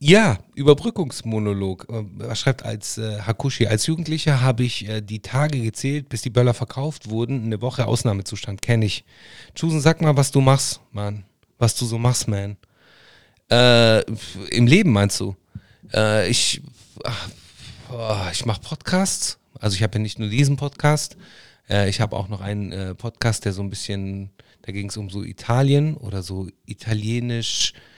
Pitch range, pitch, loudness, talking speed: 105-135 Hz, 115 Hz, -21 LUFS, 165 wpm